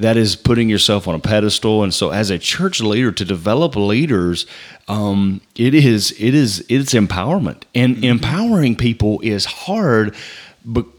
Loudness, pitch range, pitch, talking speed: -16 LUFS, 100-125 Hz, 110 Hz, 160 wpm